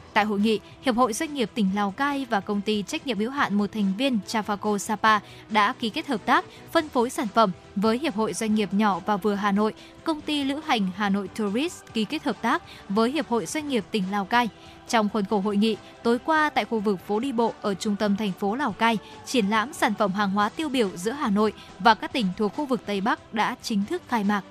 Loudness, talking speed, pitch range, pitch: -25 LUFS, 255 wpm, 205-255 Hz, 220 Hz